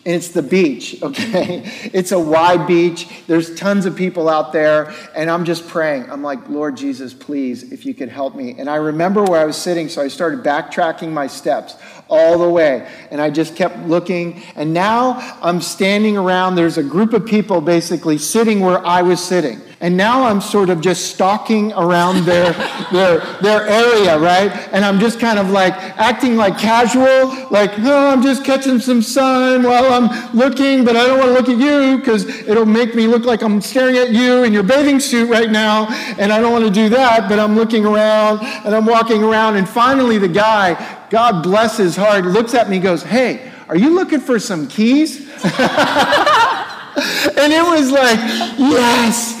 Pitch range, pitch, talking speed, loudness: 175-240 Hz, 215 Hz, 200 wpm, -14 LUFS